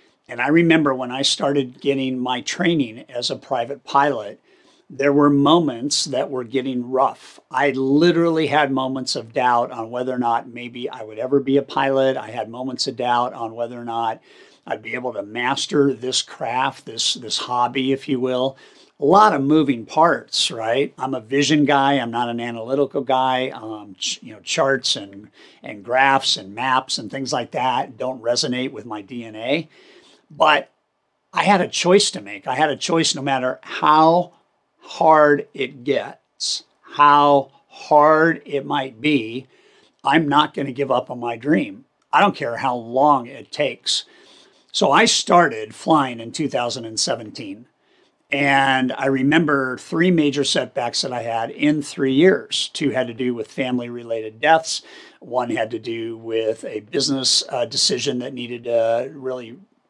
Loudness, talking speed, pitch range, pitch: -19 LUFS, 170 wpm, 120-145 Hz, 135 Hz